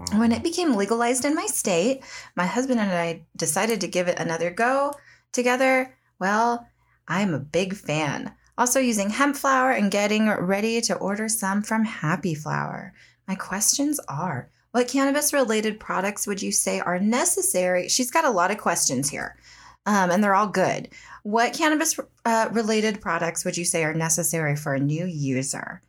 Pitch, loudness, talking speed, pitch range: 205 Hz, -23 LUFS, 170 wpm, 180-250 Hz